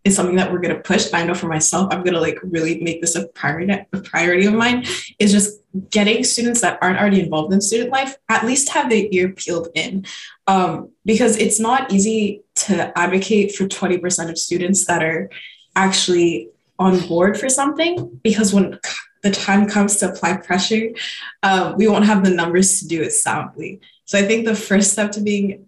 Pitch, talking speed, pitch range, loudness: 195 Hz, 195 wpm, 175-215 Hz, -17 LUFS